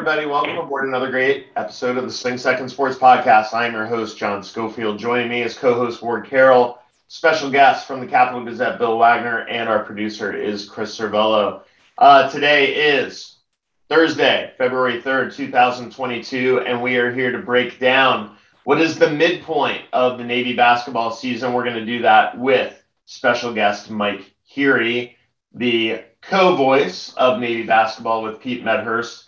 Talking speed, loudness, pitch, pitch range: 160 wpm, -18 LUFS, 120 Hz, 115-130 Hz